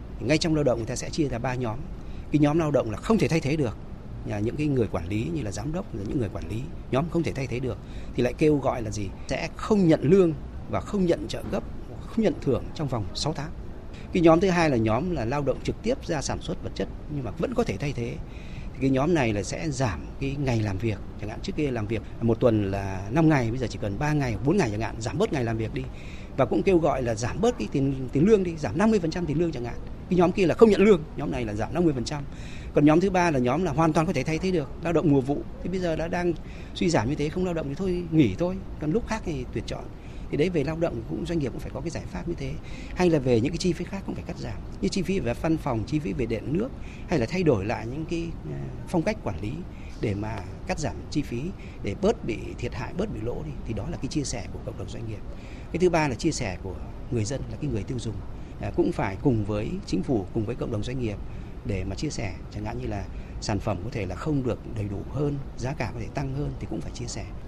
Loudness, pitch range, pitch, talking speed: -27 LUFS, 110-165 Hz, 130 Hz, 290 wpm